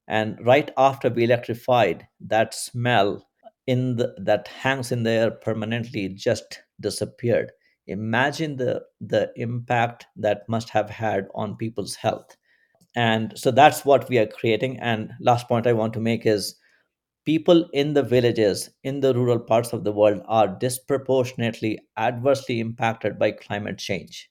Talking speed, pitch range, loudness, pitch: 150 wpm, 110-125 Hz, -23 LUFS, 115 Hz